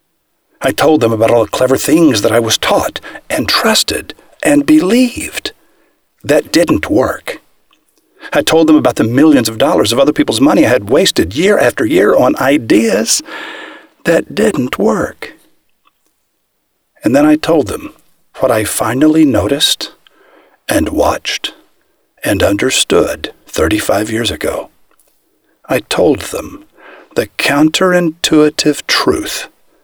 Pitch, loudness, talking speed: 290 Hz, -12 LUFS, 130 wpm